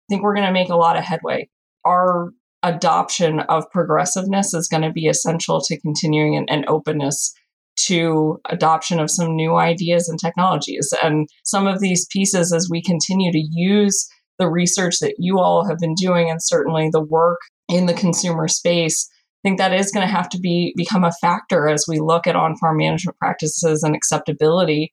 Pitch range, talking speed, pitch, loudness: 160-180 Hz, 190 wpm, 170 Hz, -18 LUFS